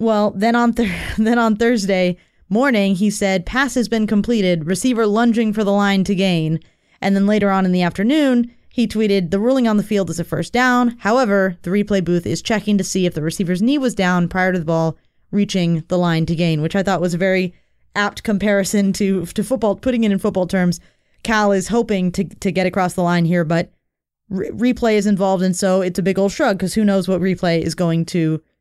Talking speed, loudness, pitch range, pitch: 225 wpm, -18 LUFS, 180-220 Hz, 195 Hz